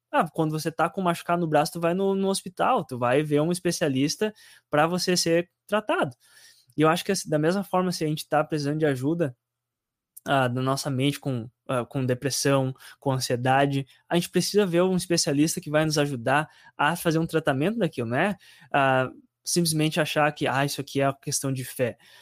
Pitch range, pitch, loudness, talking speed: 135-170 Hz, 150 Hz, -25 LUFS, 200 wpm